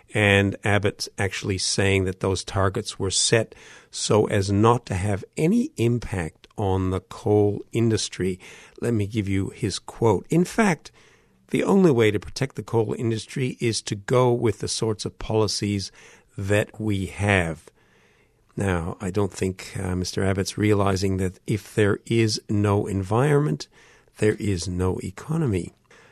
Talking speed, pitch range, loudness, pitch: 150 wpm, 95-115 Hz, -23 LUFS, 105 Hz